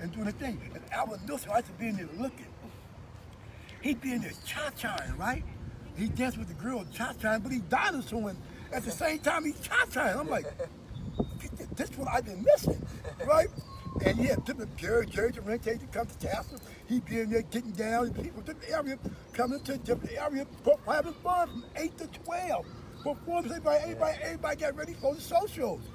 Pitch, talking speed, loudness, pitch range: 260 Hz, 205 wpm, -32 LUFS, 225-310 Hz